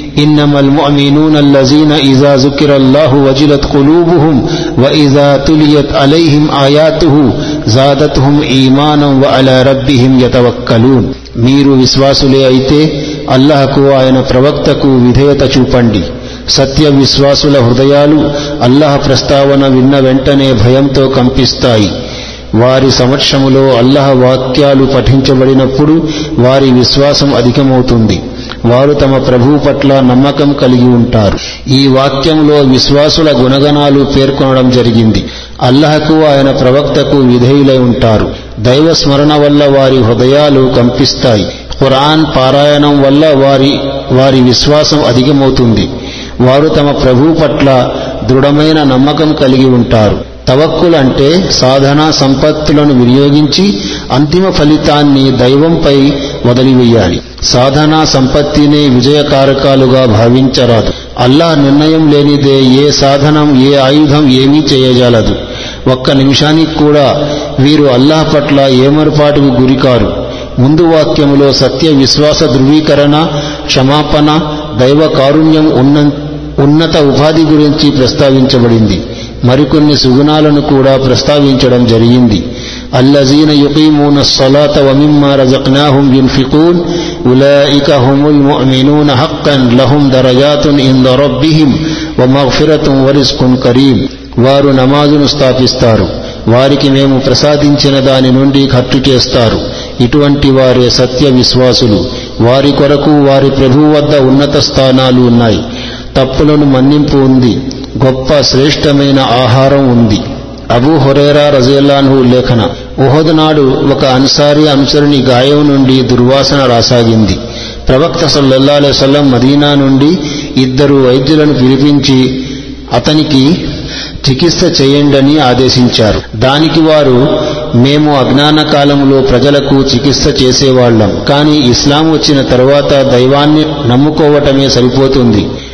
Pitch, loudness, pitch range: 140 Hz, -6 LUFS, 130-145 Hz